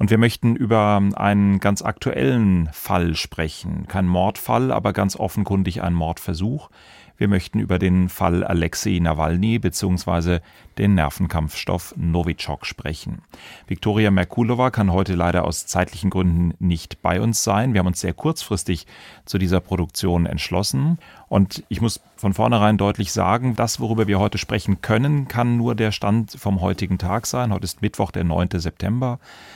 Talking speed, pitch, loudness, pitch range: 155 wpm, 100 Hz, -21 LUFS, 90-110 Hz